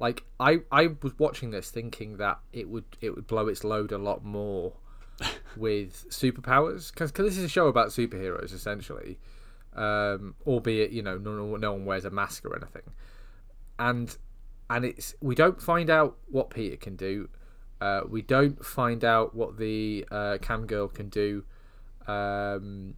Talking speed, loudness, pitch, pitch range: 165 wpm, -29 LUFS, 110 Hz, 100-120 Hz